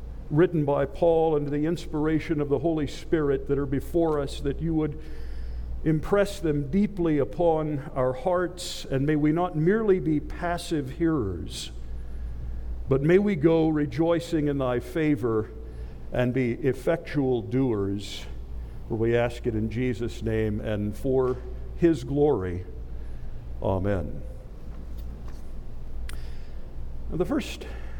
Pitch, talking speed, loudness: 130 Hz, 125 wpm, -26 LUFS